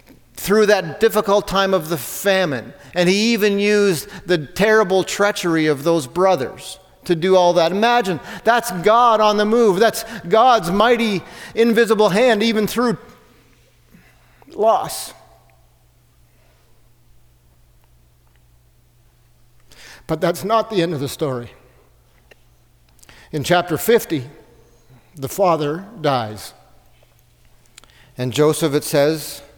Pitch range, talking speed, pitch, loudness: 130-210 Hz, 110 wpm, 175 Hz, -17 LUFS